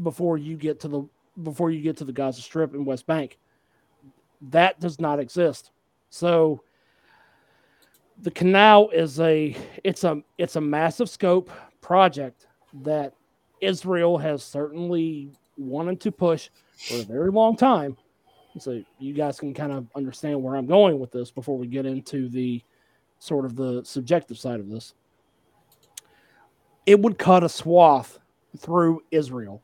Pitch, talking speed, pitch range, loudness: 155 Hz, 150 wpm, 135-175 Hz, -22 LUFS